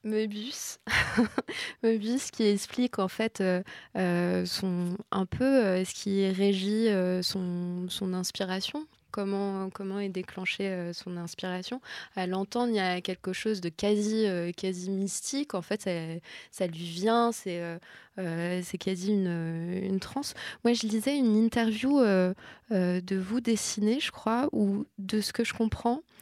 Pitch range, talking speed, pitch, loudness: 185-225 Hz, 160 wpm, 195 Hz, -30 LUFS